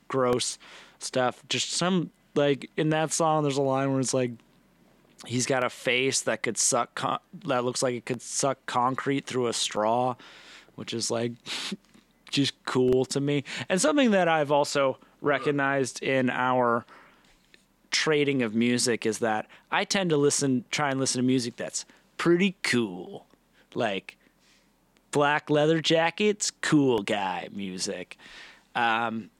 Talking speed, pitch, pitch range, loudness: 145 wpm, 135 Hz, 120-150 Hz, -26 LUFS